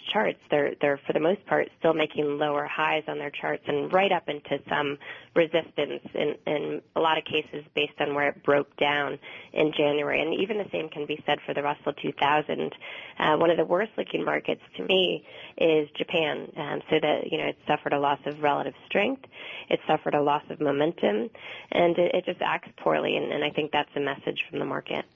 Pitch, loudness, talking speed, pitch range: 150 Hz, -27 LUFS, 215 wpm, 145-160 Hz